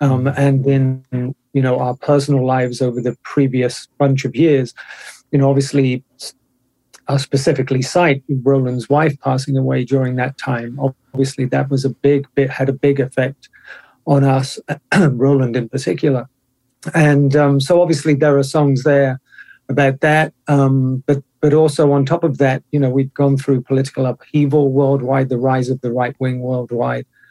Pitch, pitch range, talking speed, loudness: 135 Hz, 130-140 Hz, 165 wpm, -16 LUFS